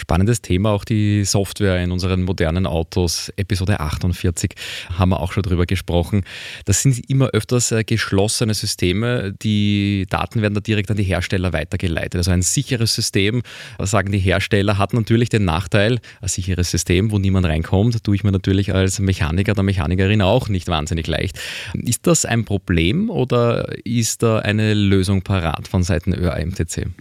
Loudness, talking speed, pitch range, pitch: -19 LUFS, 165 wpm, 90-110 Hz, 100 Hz